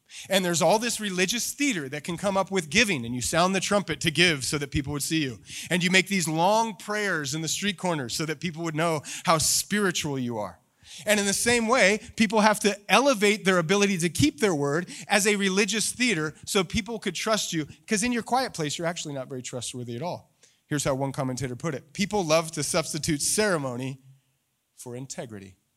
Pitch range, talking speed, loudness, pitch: 145-205 Hz, 215 wpm, -25 LUFS, 175 Hz